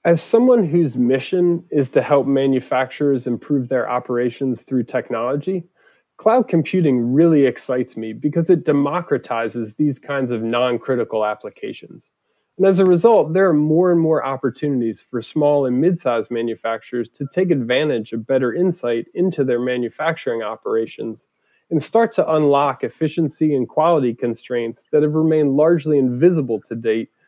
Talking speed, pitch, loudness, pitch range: 150 wpm, 140 Hz, -18 LUFS, 120-165 Hz